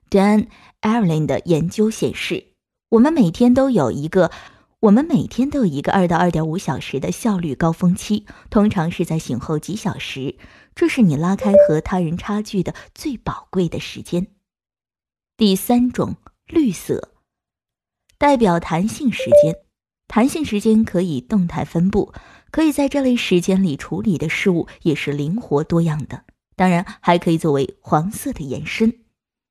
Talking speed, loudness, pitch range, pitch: 250 characters per minute, -18 LUFS, 165-225 Hz, 190 Hz